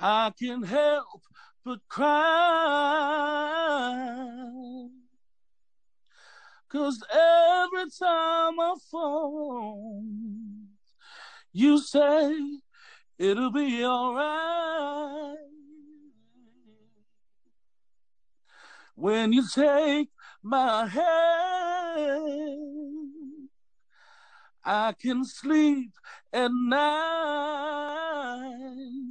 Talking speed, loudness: 55 wpm, -26 LUFS